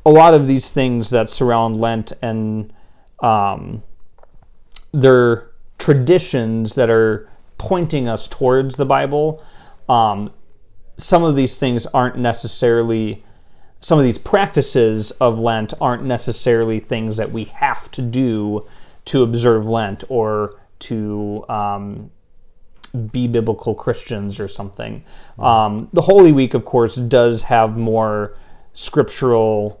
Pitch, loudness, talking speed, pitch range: 115 Hz, -16 LUFS, 125 wpm, 105-130 Hz